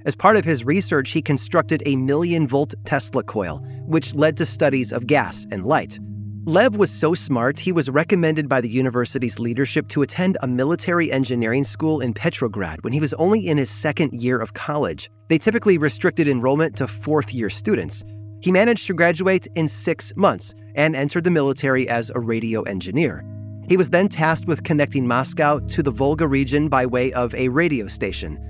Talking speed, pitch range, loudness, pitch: 185 wpm, 120-160 Hz, -20 LUFS, 135 Hz